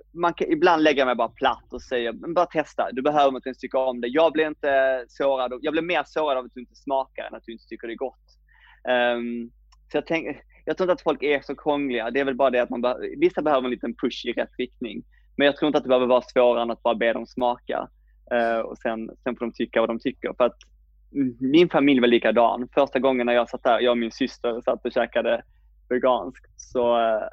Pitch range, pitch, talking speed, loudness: 120-145 Hz, 125 Hz, 255 wpm, -23 LUFS